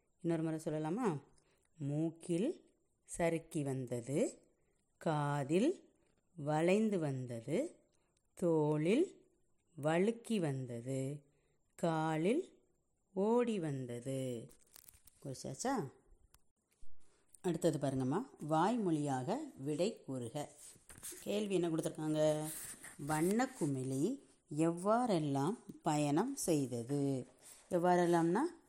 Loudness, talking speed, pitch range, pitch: -37 LUFS, 65 wpm, 145-190 Hz, 160 Hz